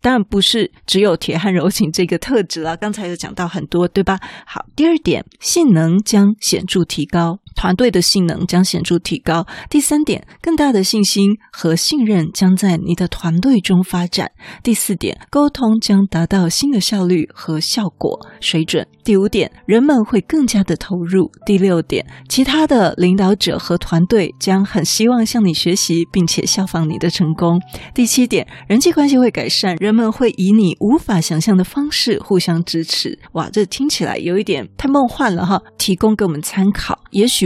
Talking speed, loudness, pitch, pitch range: 270 characters per minute, -15 LUFS, 190 Hz, 175-220 Hz